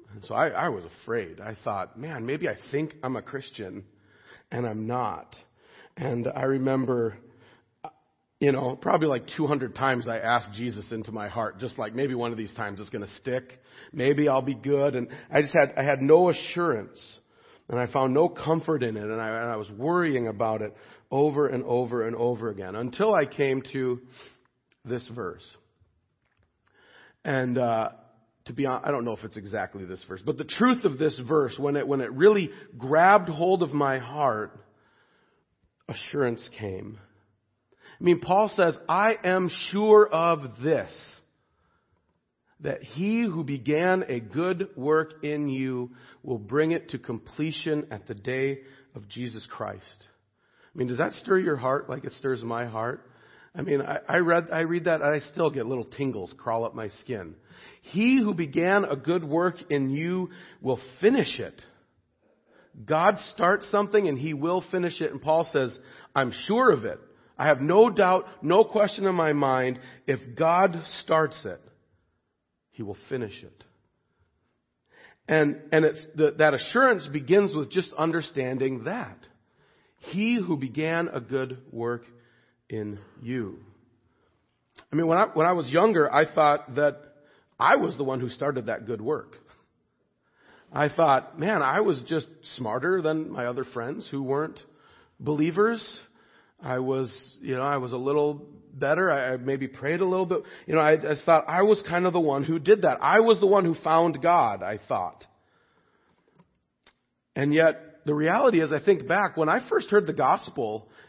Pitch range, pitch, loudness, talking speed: 125-165 Hz, 145 Hz, -26 LUFS, 175 wpm